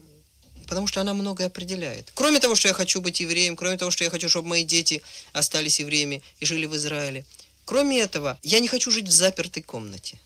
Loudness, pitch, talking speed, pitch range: -22 LUFS, 170 Hz, 205 wpm, 150-195 Hz